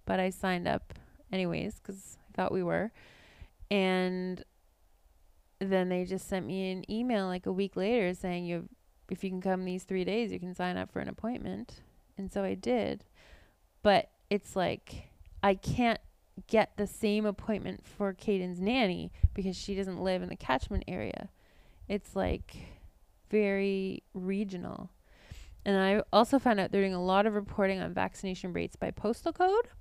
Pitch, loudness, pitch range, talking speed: 190 Hz, -32 LUFS, 175-205 Hz, 165 wpm